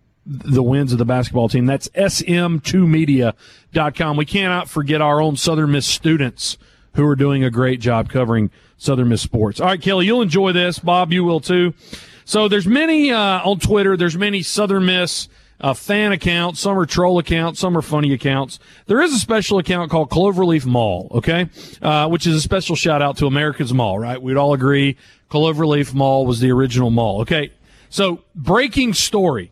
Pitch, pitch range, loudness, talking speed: 155 Hz, 135-180 Hz, -17 LUFS, 180 wpm